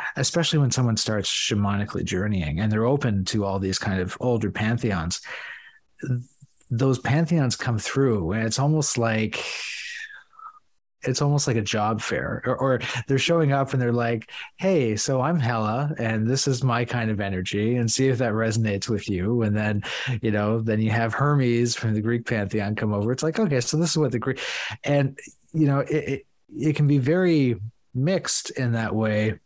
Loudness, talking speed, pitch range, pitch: -24 LUFS, 190 wpm, 110-140 Hz, 120 Hz